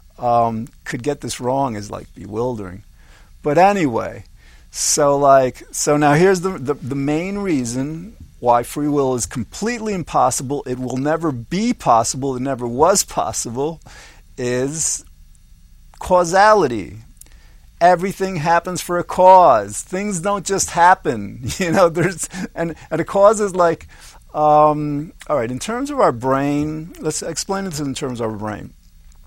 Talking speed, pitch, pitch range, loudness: 145 wpm, 145 Hz, 120-175 Hz, -18 LUFS